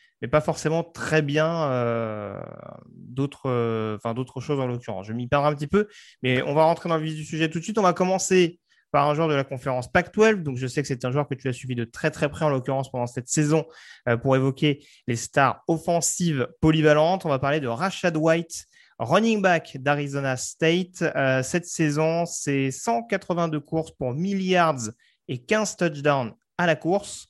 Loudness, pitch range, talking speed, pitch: -24 LUFS, 130-170 Hz, 205 wpm, 150 Hz